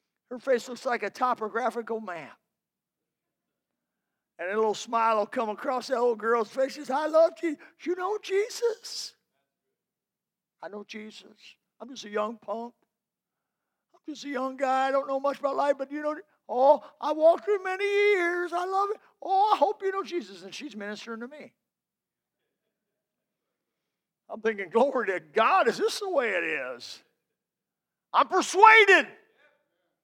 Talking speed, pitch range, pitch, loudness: 160 wpm, 230-350 Hz, 270 Hz, -26 LUFS